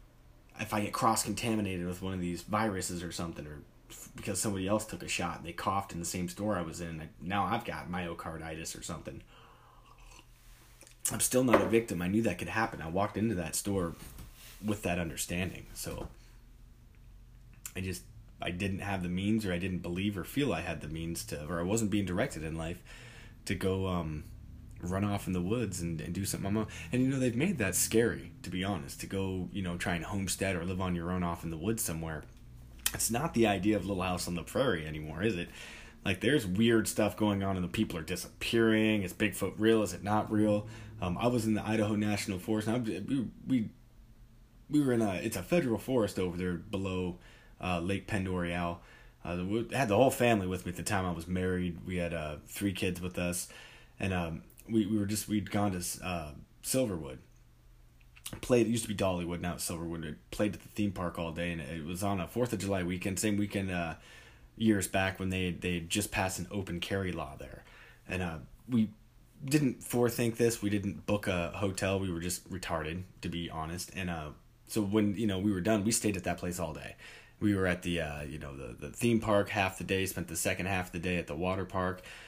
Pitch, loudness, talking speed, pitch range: 95 Hz, -33 LUFS, 225 wpm, 85-110 Hz